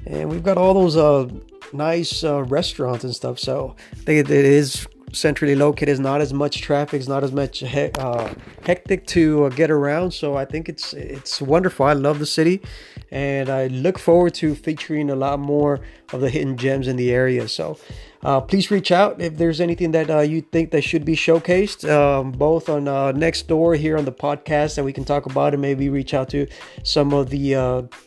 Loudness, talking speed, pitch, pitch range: -19 LUFS, 210 wpm, 145 Hz, 135-160 Hz